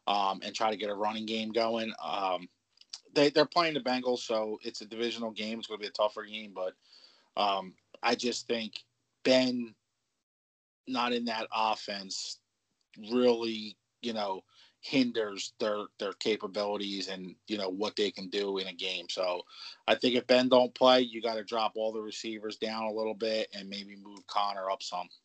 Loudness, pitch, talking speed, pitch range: -31 LUFS, 110 Hz, 185 wpm, 100-120 Hz